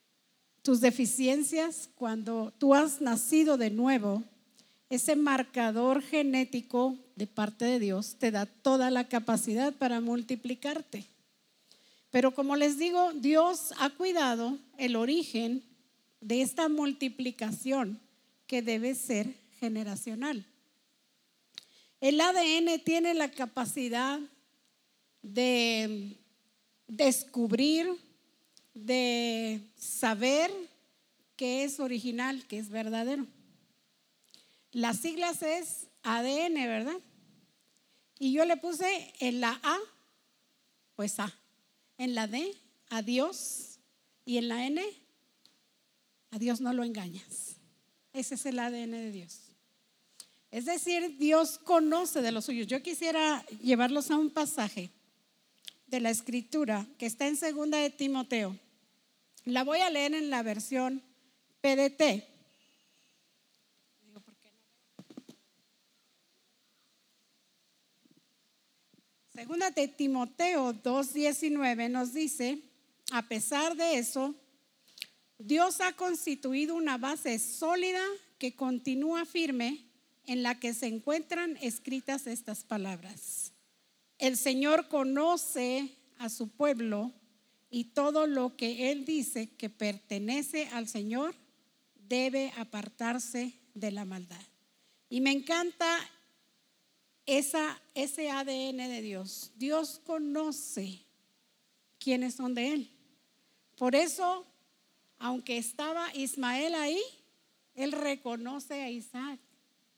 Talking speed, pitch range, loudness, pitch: 105 wpm, 235-290 Hz, -32 LUFS, 255 Hz